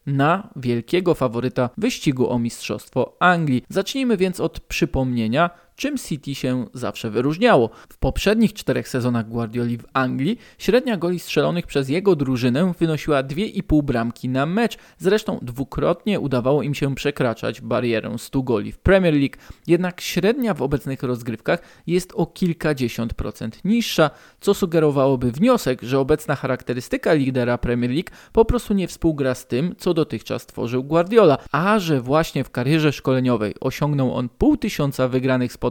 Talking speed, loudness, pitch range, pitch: 145 wpm, -21 LUFS, 125-180 Hz, 145 Hz